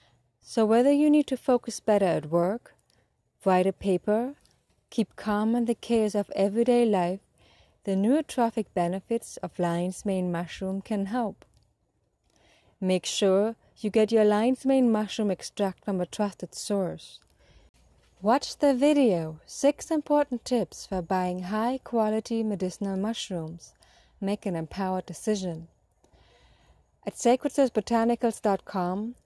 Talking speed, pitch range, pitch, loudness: 125 wpm, 185-235 Hz, 210 Hz, -27 LUFS